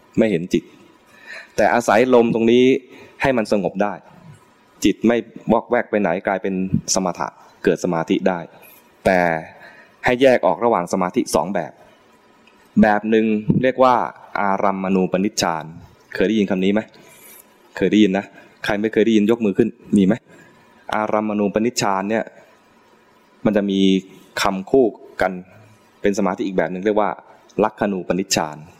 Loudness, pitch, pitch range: -19 LUFS, 105 Hz, 95-110 Hz